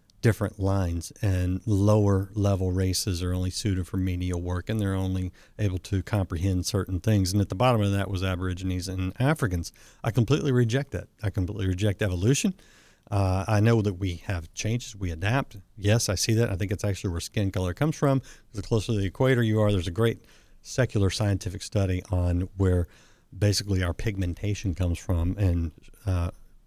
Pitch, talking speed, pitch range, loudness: 100 Hz, 180 wpm, 95-110 Hz, -27 LUFS